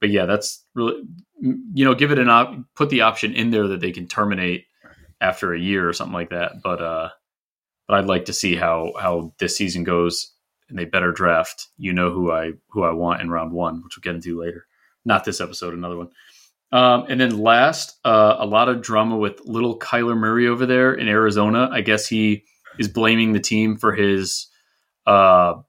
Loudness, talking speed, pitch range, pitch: -19 LUFS, 210 wpm, 90-115 Hz, 105 Hz